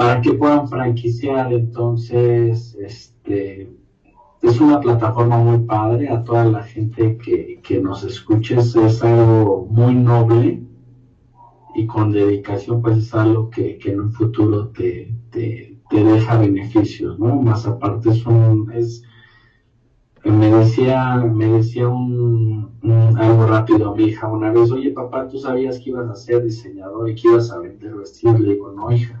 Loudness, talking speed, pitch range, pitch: -16 LUFS, 155 wpm, 110-120 Hz, 115 Hz